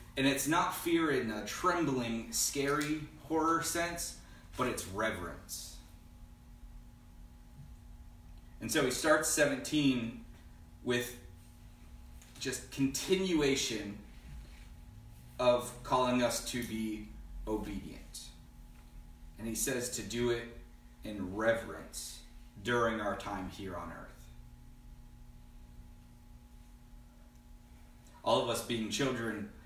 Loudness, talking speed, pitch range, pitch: -34 LUFS, 95 wpm, 80-120 Hz, 110 Hz